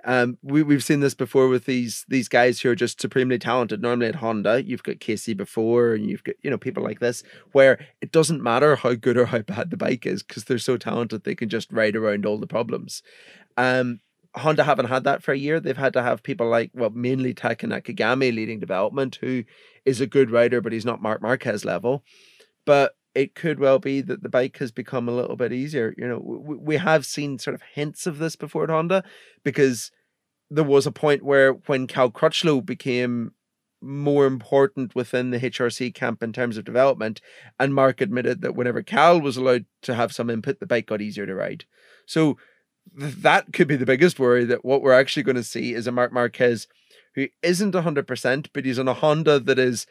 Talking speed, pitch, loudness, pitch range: 215 wpm, 130 Hz, -22 LUFS, 120-140 Hz